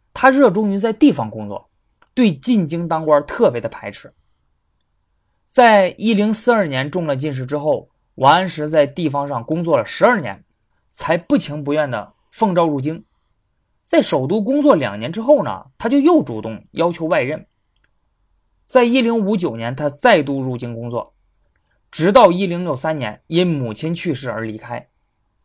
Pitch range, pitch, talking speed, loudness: 130-215 Hz, 160 Hz, 240 characters per minute, -17 LUFS